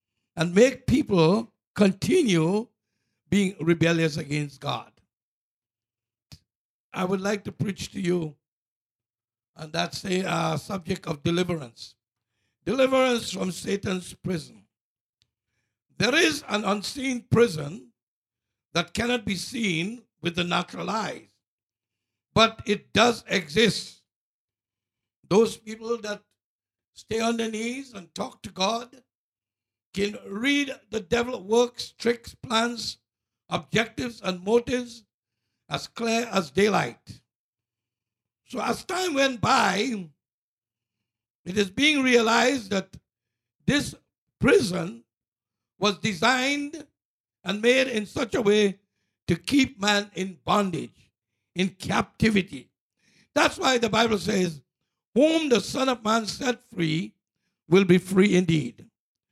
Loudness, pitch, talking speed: -25 LUFS, 185 Hz, 110 wpm